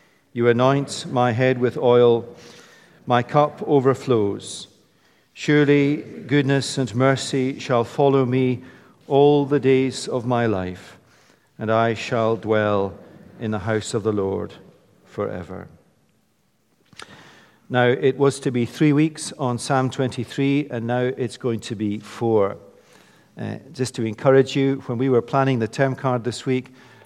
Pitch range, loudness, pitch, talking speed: 120-135 Hz, -21 LUFS, 130 Hz, 140 wpm